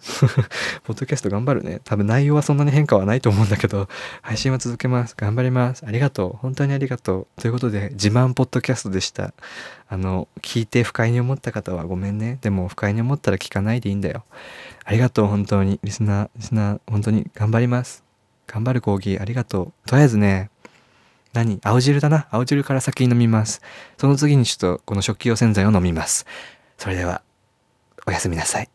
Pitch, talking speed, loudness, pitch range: 115 Hz, 410 characters per minute, -20 LUFS, 100-130 Hz